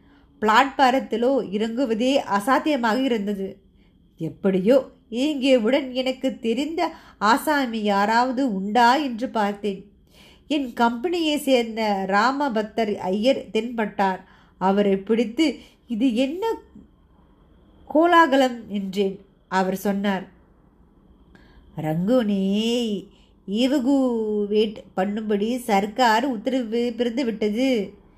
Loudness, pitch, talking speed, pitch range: -22 LUFS, 230 Hz, 70 wpm, 205-265 Hz